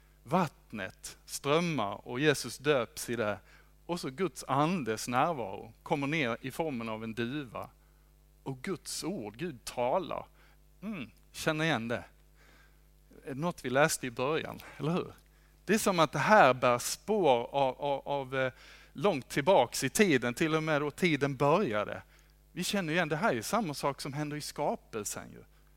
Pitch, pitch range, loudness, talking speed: 145 Hz, 125-160 Hz, -31 LUFS, 165 wpm